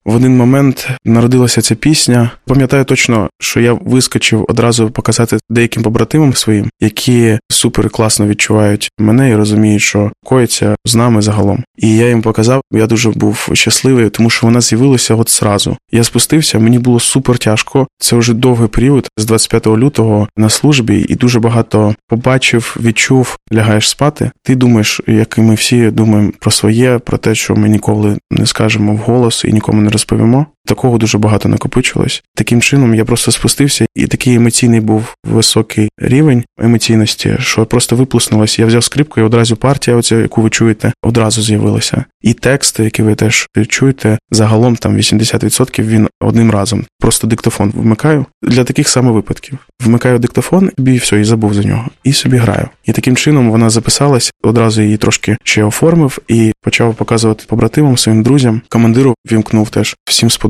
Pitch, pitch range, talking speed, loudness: 115 Hz, 110-125 Hz, 165 wpm, -10 LUFS